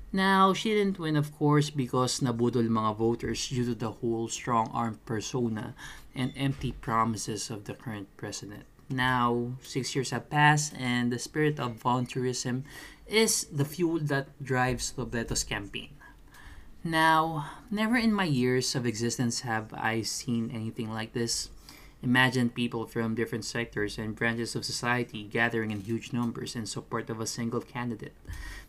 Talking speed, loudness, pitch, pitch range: 155 wpm, -29 LUFS, 120 Hz, 115-135 Hz